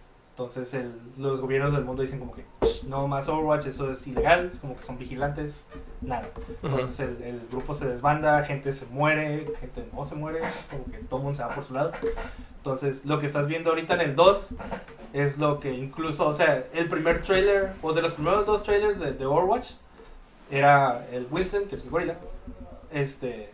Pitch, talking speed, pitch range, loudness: 140 Hz, 205 wpm, 130-160 Hz, -27 LUFS